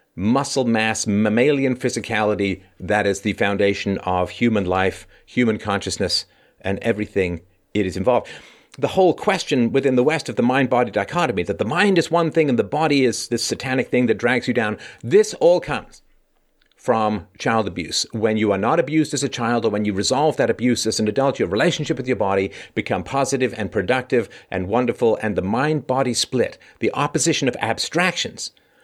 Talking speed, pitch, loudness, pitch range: 185 wpm, 115 Hz, -20 LUFS, 100-135 Hz